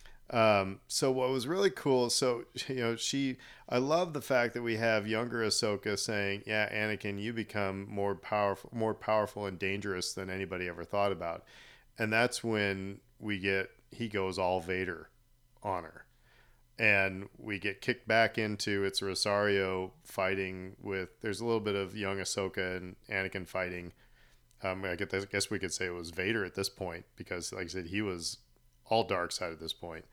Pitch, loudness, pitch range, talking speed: 100 Hz, -33 LUFS, 95-115 Hz, 180 wpm